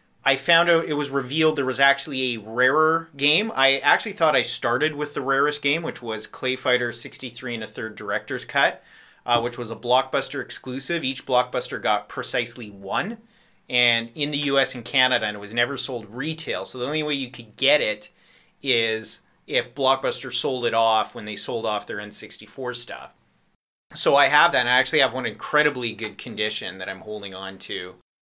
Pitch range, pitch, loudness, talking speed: 115-145 Hz, 125 Hz, -23 LUFS, 195 wpm